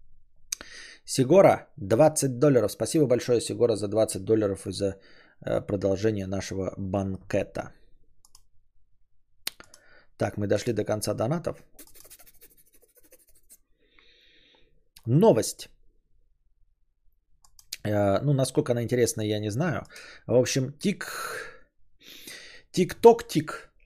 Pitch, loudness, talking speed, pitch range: 105 Hz, -25 LUFS, 80 wpm, 95-150 Hz